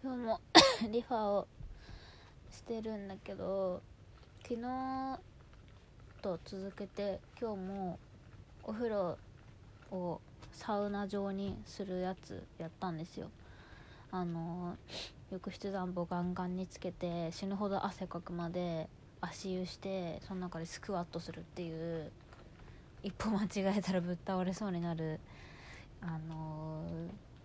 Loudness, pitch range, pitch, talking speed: -38 LUFS, 165-200 Hz, 185 Hz, 230 characters per minute